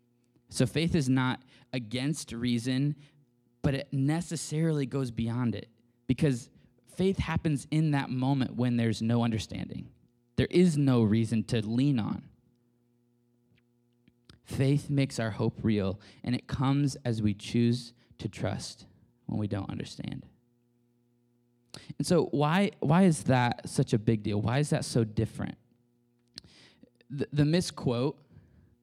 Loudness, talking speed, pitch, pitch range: -29 LUFS, 135 wpm, 120 Hz, 120-140 Hz